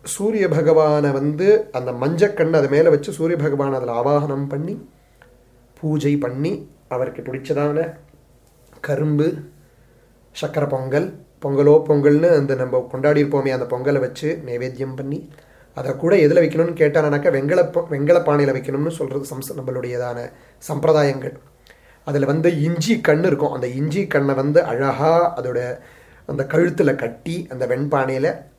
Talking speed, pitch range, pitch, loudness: 125 wpm, 135-160 Hz, 145 Hz, -19 LUFS